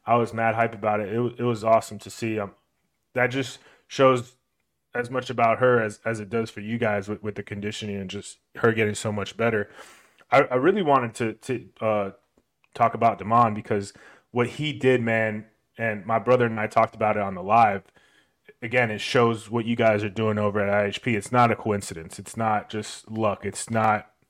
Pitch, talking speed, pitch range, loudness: 110 Hz, 215 wpm, 105-120 Hz, -24 LUFS